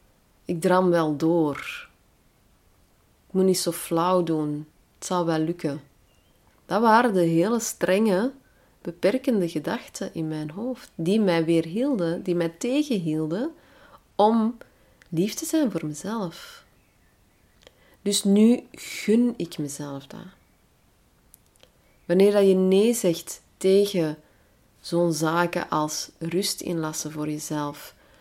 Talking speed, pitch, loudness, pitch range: 115 wpm, 170 Hz, -24 LUFS, 155-200 Hz